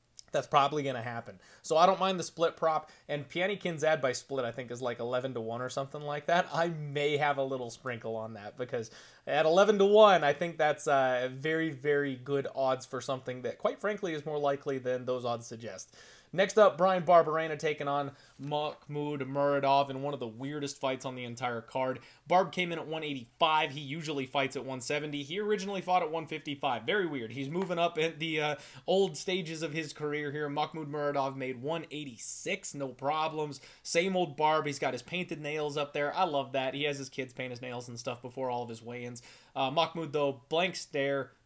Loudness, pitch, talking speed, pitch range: -31 LUFS, 145 Hz, 215 wpm, 130-160 Hz